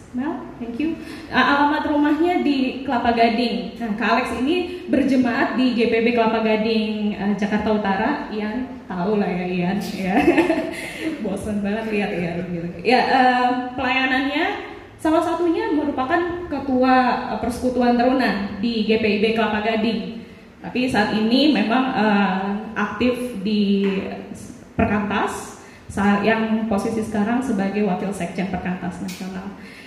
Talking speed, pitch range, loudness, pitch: 120 wpm, 210-260 Hz, -20 LUFS, 230 Hz